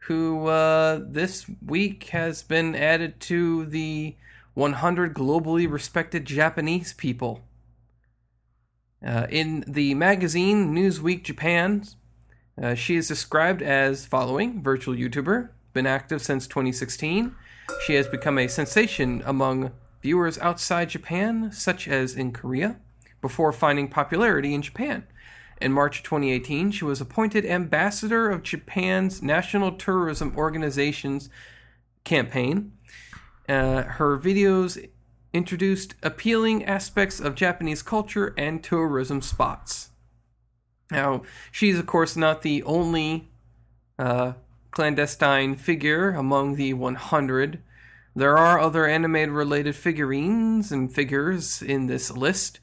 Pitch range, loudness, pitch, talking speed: 130-175 Hz, -24 LUFS, 150 Hz, 110 wpm